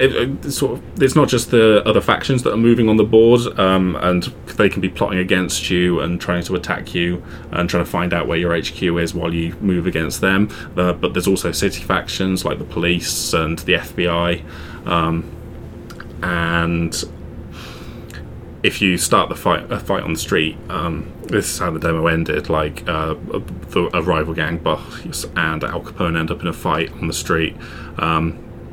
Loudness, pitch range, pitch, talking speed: -18 LUFS, 85-95 Hz, 85 Hz, 190 wpm